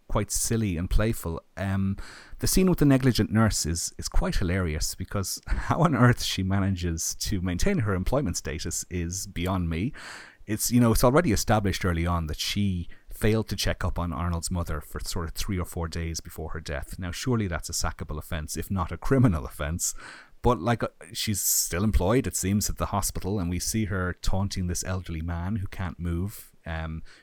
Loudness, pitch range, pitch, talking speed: -27 LUFS, 85-105 Hz, 90 Hz, 200 wpm